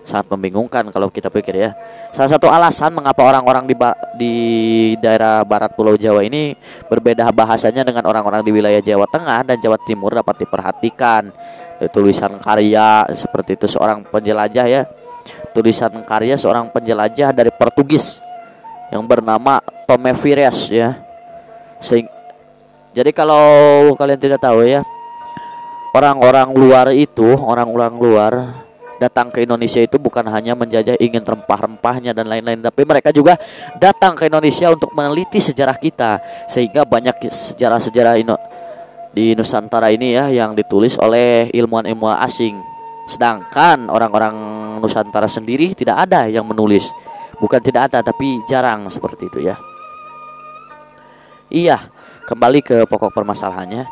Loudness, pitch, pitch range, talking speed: -13 LUFS, 120 Hz, 110-160 Hz, 130 wpm